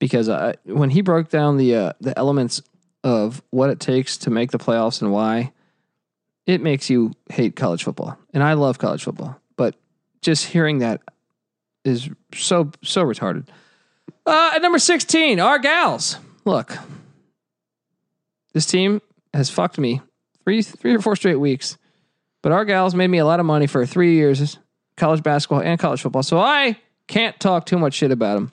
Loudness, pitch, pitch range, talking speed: -19 LUFS, 155 Hz, 135-185 Hz, 175 wpm